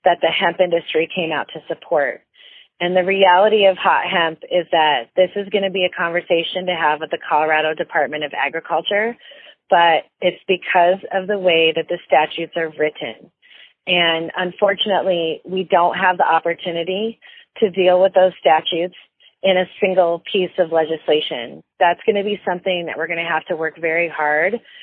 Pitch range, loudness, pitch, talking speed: 165-190 Hz, -18 LUFS, 175 Hz, 170 wpm